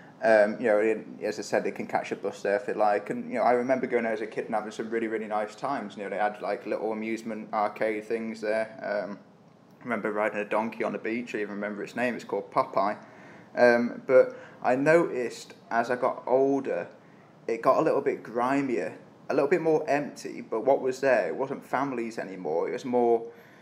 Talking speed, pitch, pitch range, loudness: 225 wpm, 115 Hz, 110-135 Hz, -28 LUFS